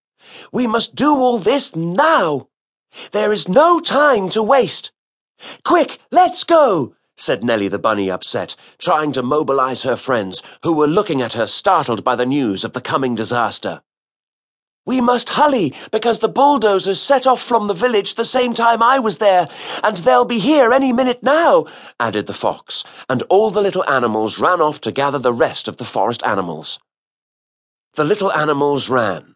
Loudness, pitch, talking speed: -16 LUFS, 205 Hz, 170 wpm